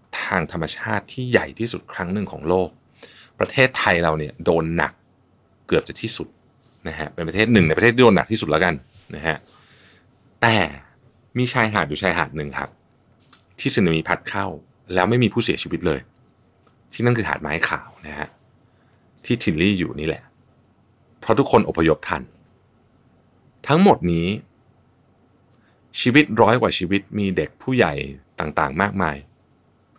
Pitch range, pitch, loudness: 85-120 Hz, 100 Hz, -20 LUFS